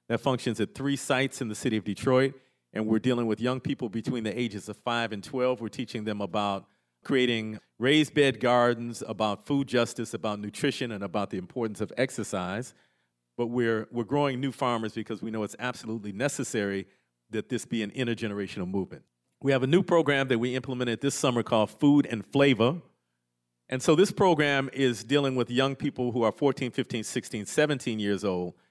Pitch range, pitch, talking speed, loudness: 110-135 Hz, 120 Hz, 190 wpm, -28 LUFS